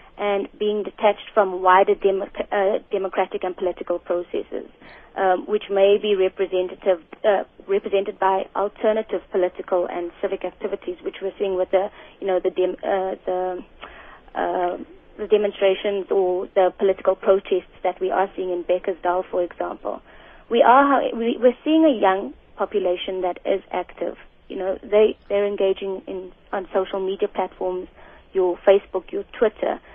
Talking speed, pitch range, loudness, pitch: 150 wpm, 185-205 Hz, -22 LUFS, 195 Hz